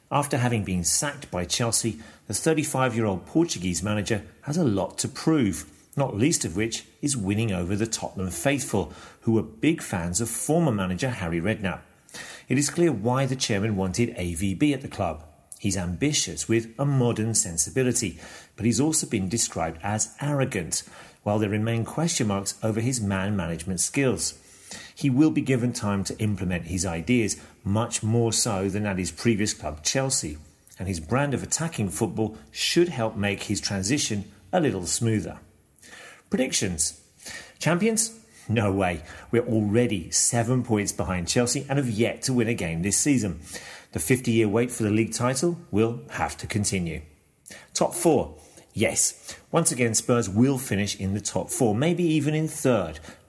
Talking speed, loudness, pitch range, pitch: 165 wpm, -25 LUFS, 95-130 Hz, 110 Hz